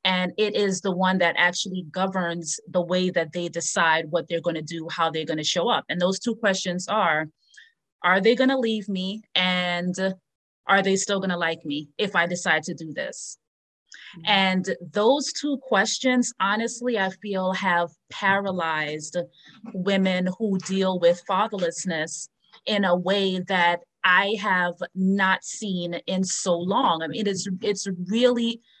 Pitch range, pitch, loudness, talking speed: 170-200 Hz, 185 Hz, -24 LUFS, 165 wpm